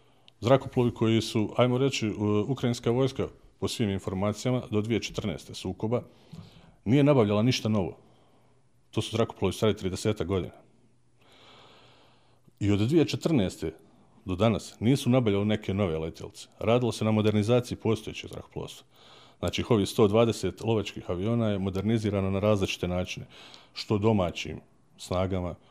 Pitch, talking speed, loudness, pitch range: 110 Hz, 120 wpm, -28 LUFS, 100-120 Hz